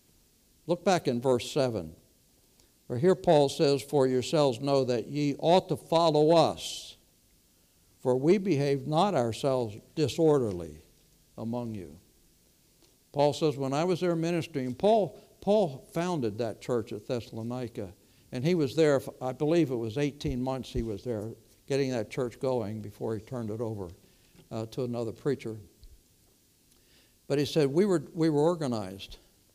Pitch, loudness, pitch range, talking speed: 130 Hz, -29 LUFS, 110-150 Hz, 150 wpm